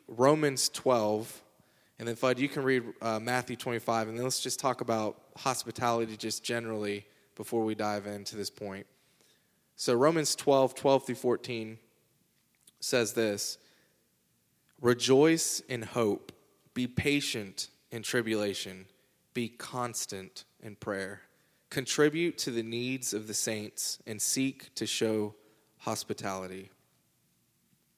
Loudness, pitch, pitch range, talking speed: -31 LUFS, 115 Hz, 105-130 Hz, 120 wpm